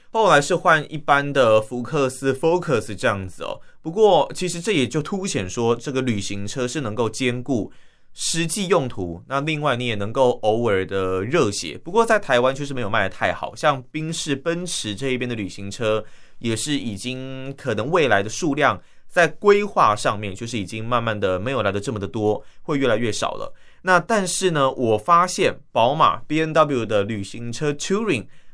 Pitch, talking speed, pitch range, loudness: 130 Hz, 290 characters per minute, 110-160 Hz, -21 LUFS